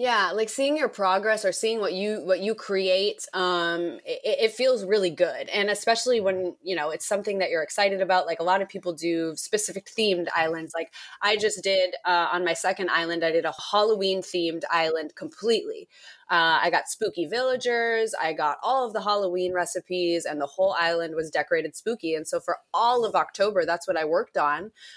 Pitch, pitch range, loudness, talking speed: 190 Hz, 170-220 Hz, -25 LUFS, 200 wpm